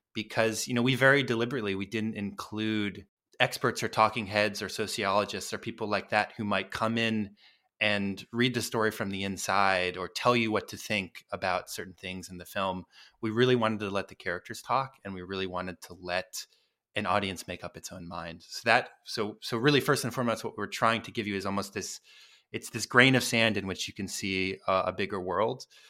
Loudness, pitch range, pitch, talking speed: -29 LUFS, 95-115 Hz, 105 Hz, 220 wpm